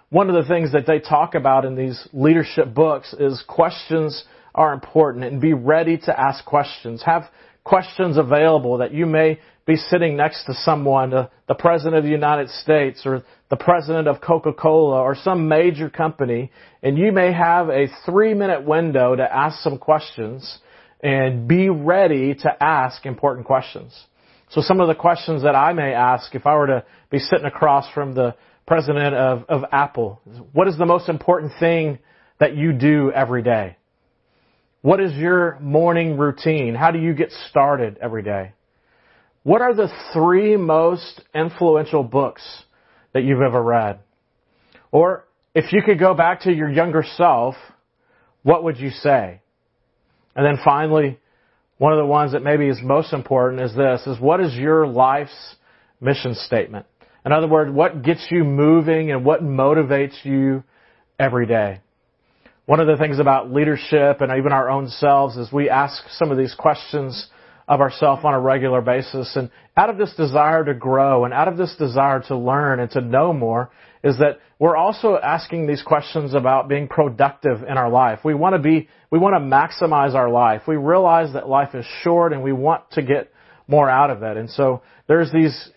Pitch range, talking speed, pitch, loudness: 135-160 Hz, 180 wpm, 150 Hz, -18 LUFS